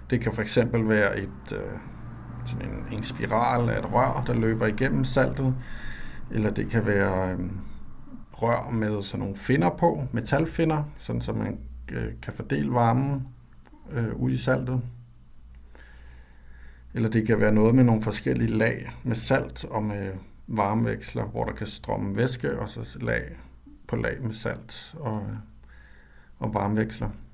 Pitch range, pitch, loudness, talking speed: 100-125 Hz, 110 Hz, -27 LUFS, 145 wpm